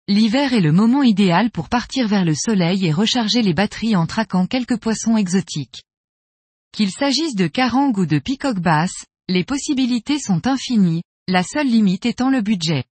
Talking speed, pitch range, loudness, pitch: 170 wpm, 180-245 Hz, -18 LUFS, 215 Hz